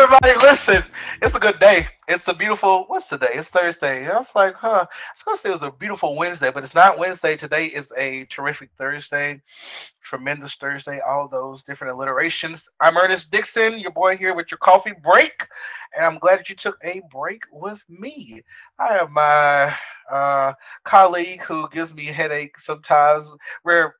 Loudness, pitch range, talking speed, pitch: -18 LUFS, 145-195 Hz, 185 wpm, 170 Hz